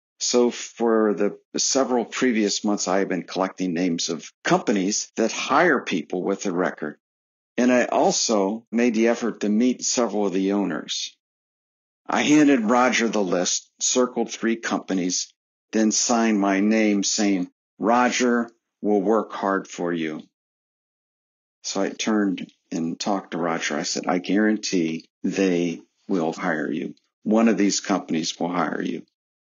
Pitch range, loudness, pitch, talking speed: 95-115 Hz, -22 LUFS, 105 Hz, 145 wpm